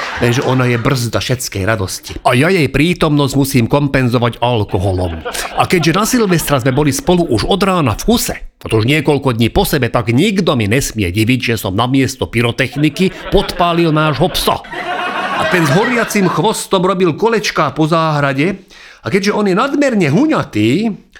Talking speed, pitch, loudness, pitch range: 165 wpm, 145 Hz, -13 LUFS, 120-185 Hz